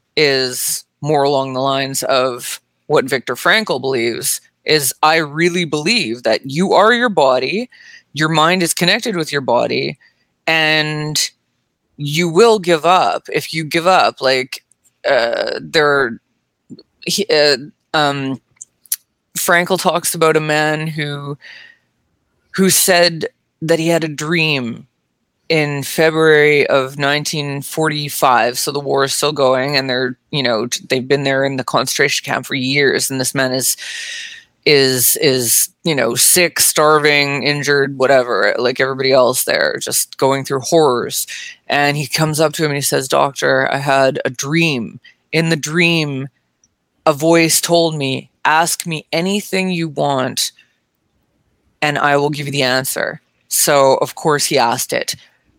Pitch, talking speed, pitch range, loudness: 150 Hz, 145 wpm, 135-165 Hz, -15 LUFS